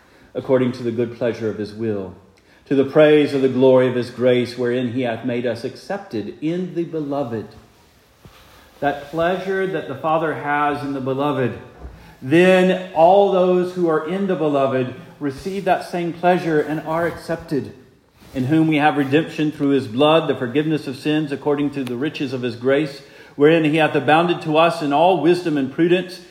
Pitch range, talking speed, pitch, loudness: 130-165 Hz, 180 wpm, 145 Hz, -19 LUFS